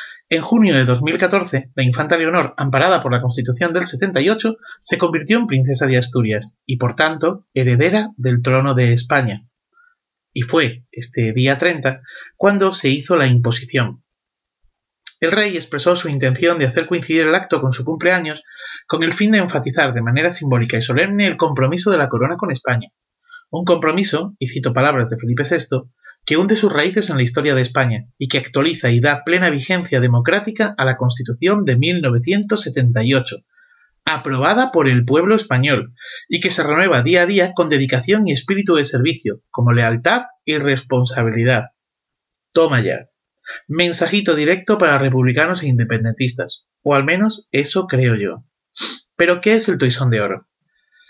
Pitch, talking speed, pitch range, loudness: 145 Hz, 165 wpm, 125-175 Hz, -16 LUFS